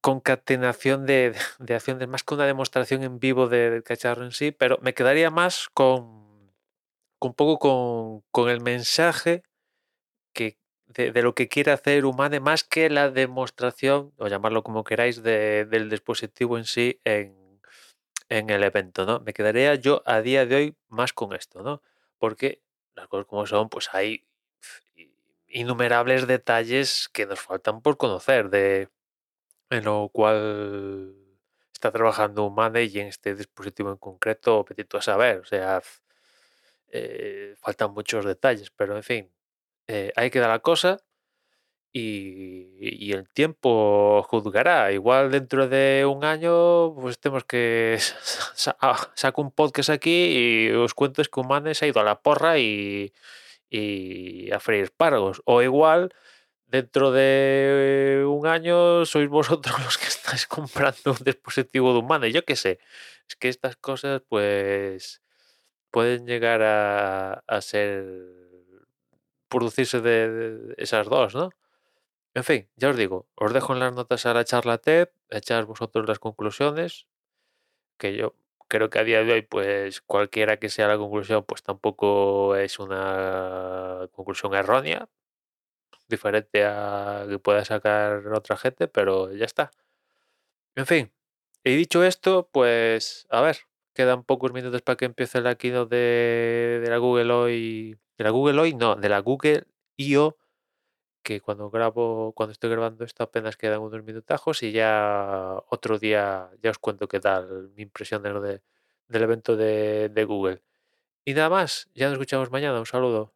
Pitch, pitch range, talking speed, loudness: 120 Hz, 105-135 Hz, 160 wpm, -23 LUFS